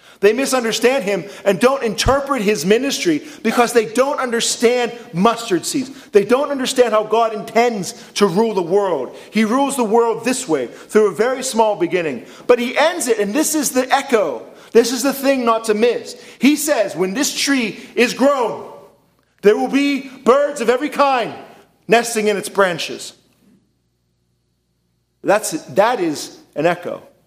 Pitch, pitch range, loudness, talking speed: 235 Hz, 215-275 Hz, -17 LUFS, 165 wpm